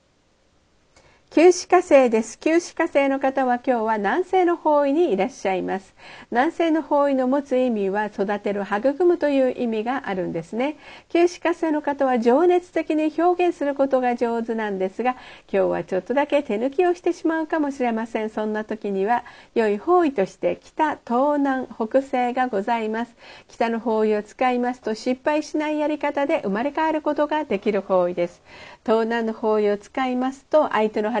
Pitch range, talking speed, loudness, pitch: 220-300 Hz, 350 characters per minute, -22 LUFS, 255 Hz